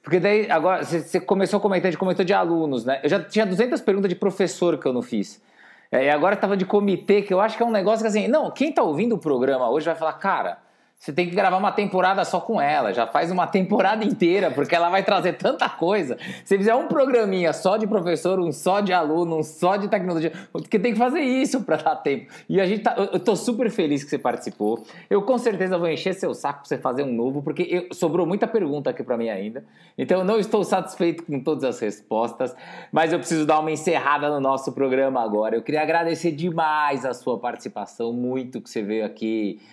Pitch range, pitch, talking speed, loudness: 155-205 Hz, 180 Hz, 235 wpm, -22 LUFS